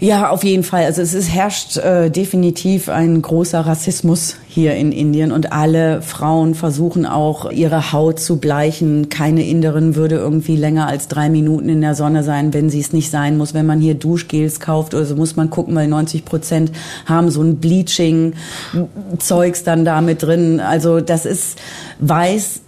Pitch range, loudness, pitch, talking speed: 155-170 Hz, -15 LUFS, 160 Hz, 180 wpm